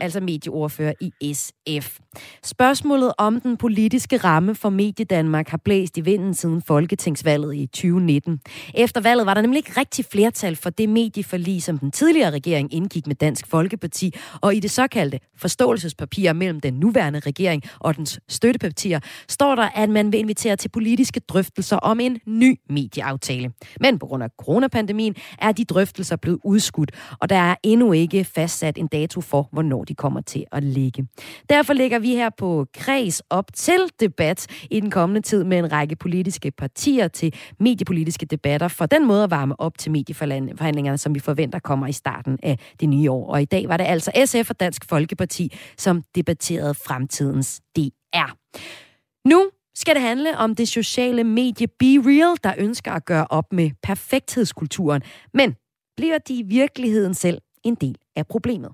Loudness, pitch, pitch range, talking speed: -20 LUFS, 180 Hz, 150-225 Hz, 170 wpm